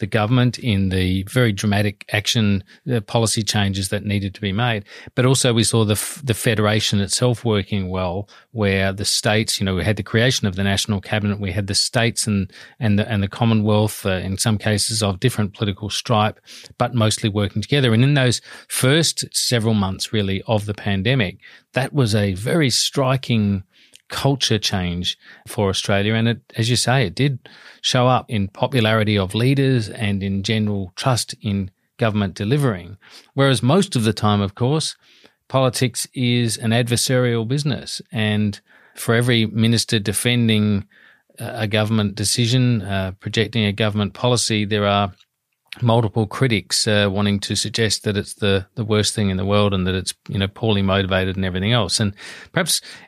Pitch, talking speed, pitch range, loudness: 110 Hz, 175 wpm, 100-120 Hz, -19 LUFS